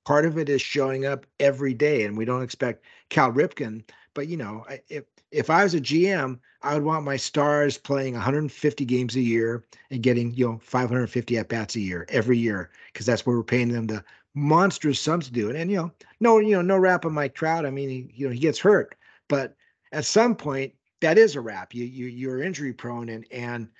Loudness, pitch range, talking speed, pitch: -24 LUFS, 120-155 Hz, 230 wpm, 135 Hz